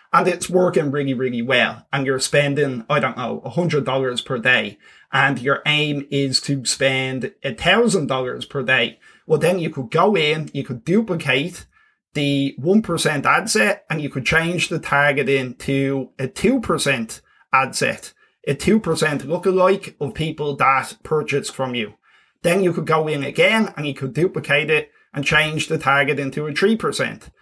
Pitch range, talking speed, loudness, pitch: 135-165 Hz, 165 wpm, -19 LUFS, 145 Hz